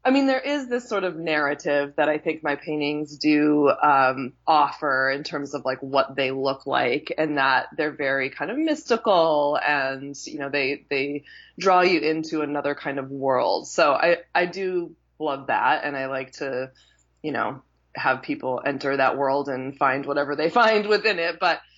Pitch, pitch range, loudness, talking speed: 145 Hz, 135-165 Hz, -23 LUFS, 185 wpm